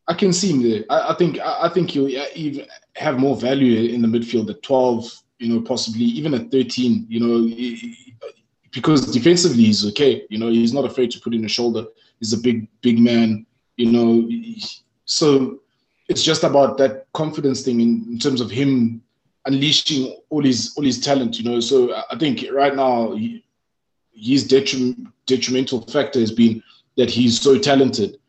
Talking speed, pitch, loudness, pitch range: 185 wpm, 130 Hz, -18 LUFS, 115-140 Hz